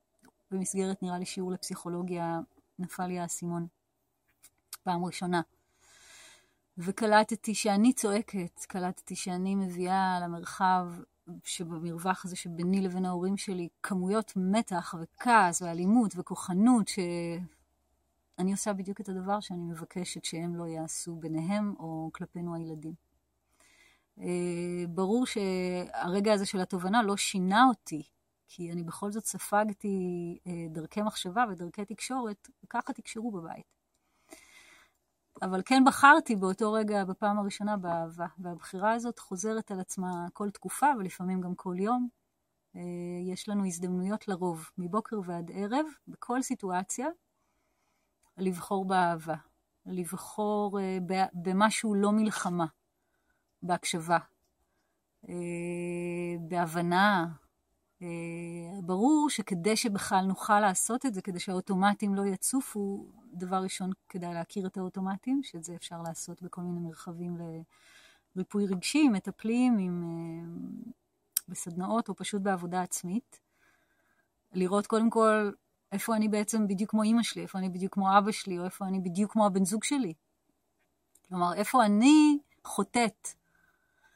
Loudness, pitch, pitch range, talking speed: -31 LUFS, 190 Hz, 175-220 Hz, 115 wpm